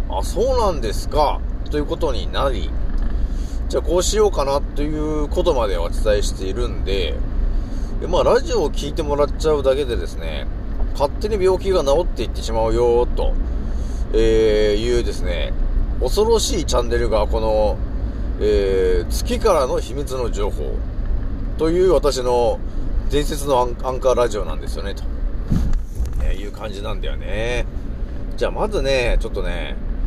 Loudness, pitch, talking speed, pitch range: -21 LUFS, 120 Hz, 315 characters per minute, 105-155 Hz